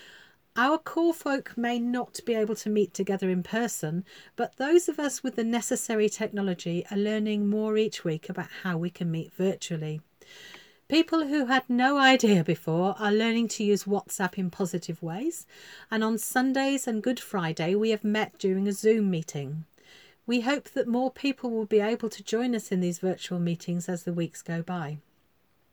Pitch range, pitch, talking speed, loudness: 180-245 Hz, 215 Hz, 180 wpm, -28 LUFS